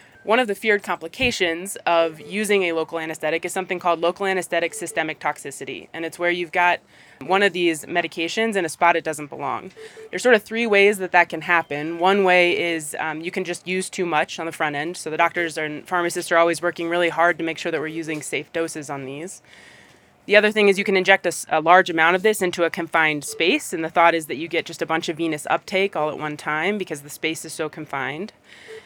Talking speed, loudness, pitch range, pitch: 240 wpm, -21 LUFS, 160-185 Hz, 170 Hz